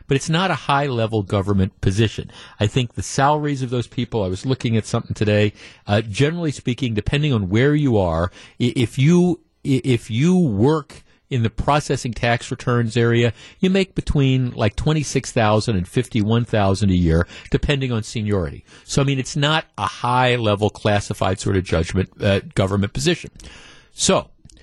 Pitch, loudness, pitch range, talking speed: 120 Hz, -20 LUFS, 105-140 Hz, 165 wpm